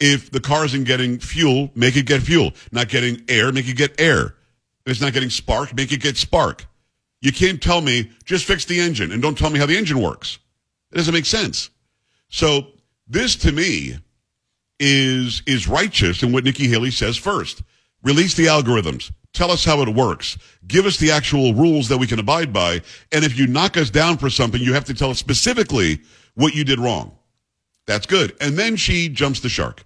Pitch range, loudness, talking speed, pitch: 120-150 Hz, -18 LUFS, 205 wpm, 135 Hz